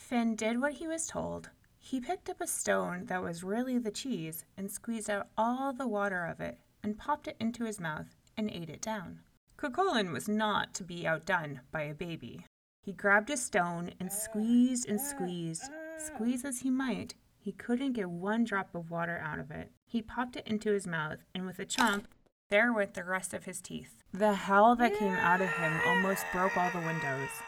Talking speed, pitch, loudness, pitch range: 205 wpm, 205 Hz, -33 LUFS, 180-240 Hz